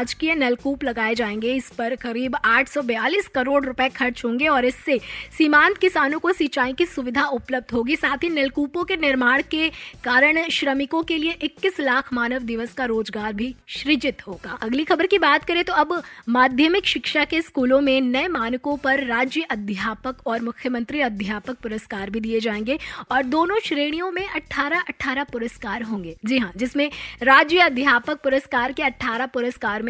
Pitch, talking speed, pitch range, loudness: 265 Hz, 165 wpm, 240-305 Hz, -21 LUFS